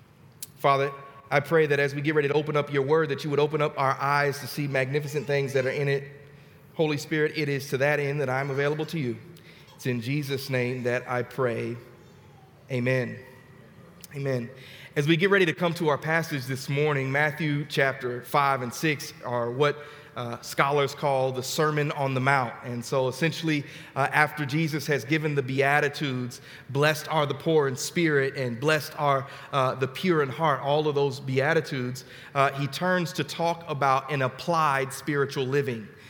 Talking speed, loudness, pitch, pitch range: 190 wpm, -26 LUFS, 140 Hz, 135-150 Hz